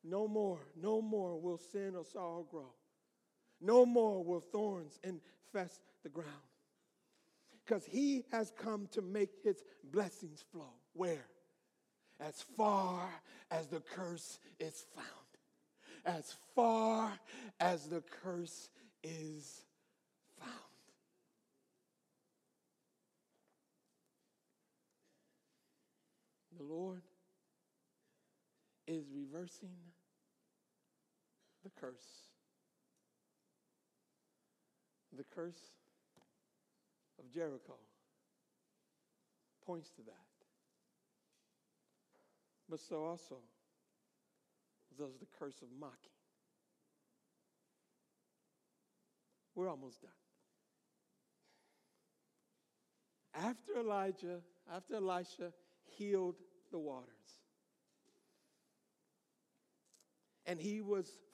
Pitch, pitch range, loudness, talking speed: 180 Hz, 165-210 Hz, -41 LUFS, 70 wpm